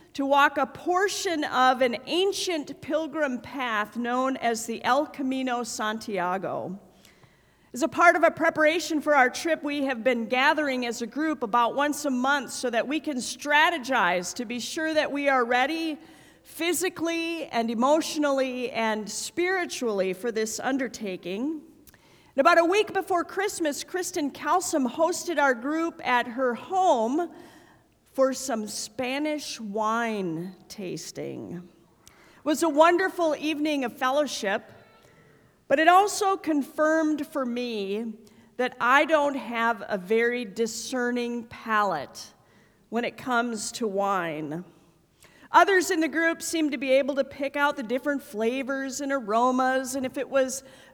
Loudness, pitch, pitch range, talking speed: -25 LUFS, 270 Hz, 235-315 Hz, 140 wpm